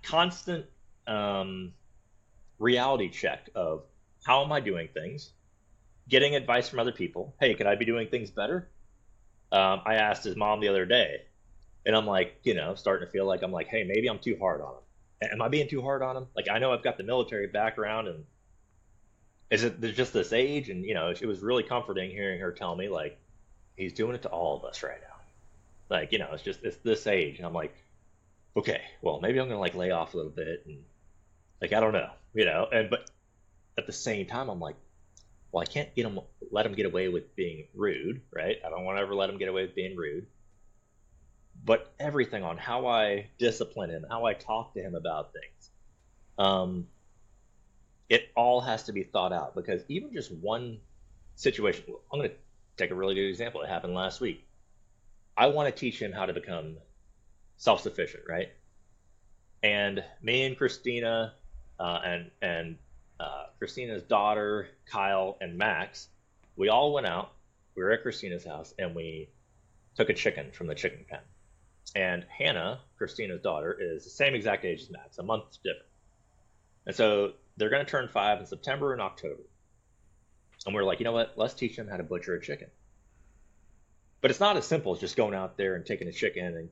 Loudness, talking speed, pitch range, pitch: -30 LUFS, 195 wpm, 95-115 Hz, 100 Hz